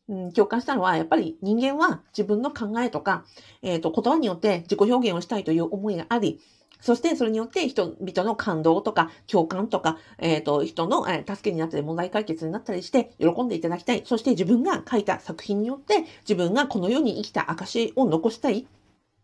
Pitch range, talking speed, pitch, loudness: 175-240 Hz, 400 characters per minute, 210 Hz, -25 LUFS